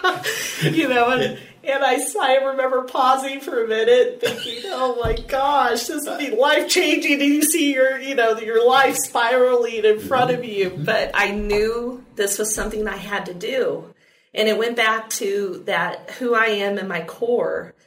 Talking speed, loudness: 185 wpm, -19 LUFS